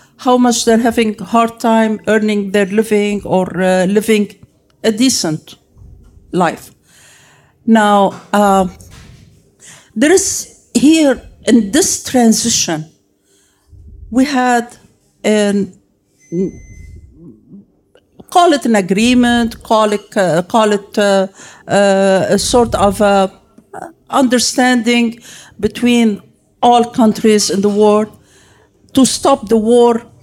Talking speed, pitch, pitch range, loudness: 105 wpm, 215 Hz, 195-235 Hz, -13 LUFS